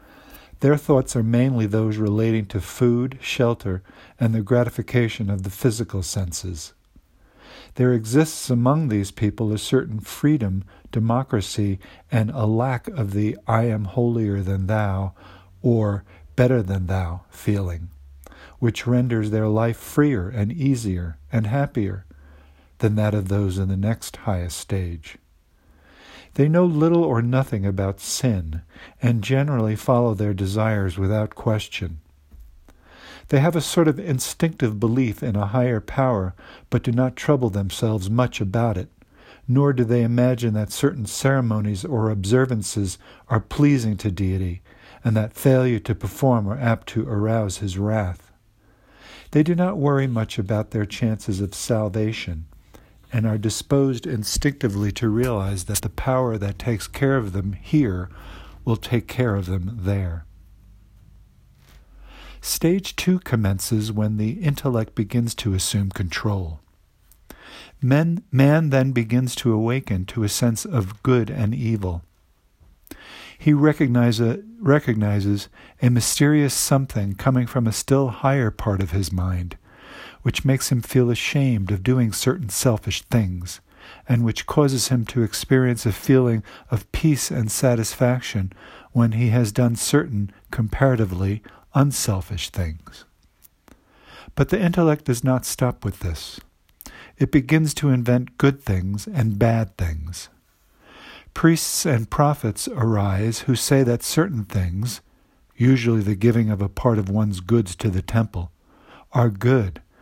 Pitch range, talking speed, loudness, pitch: 100-125 Hz, 140 wpm, -22 LUFS, 110 Hz